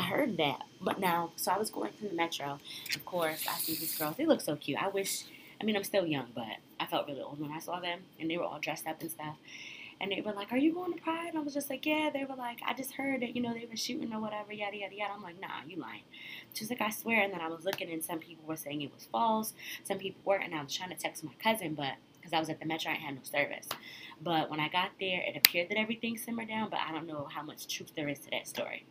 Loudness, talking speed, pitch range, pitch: -35 LUFS, 300 wpm, 155-220 Hz, 180 Hz